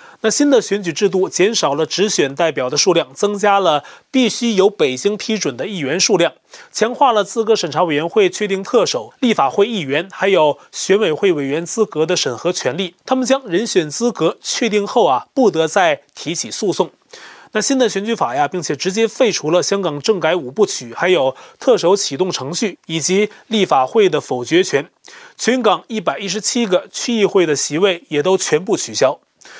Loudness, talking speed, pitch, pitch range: -16 LUFS, 285 characters per minute, 205 Hz, 180-235 Hz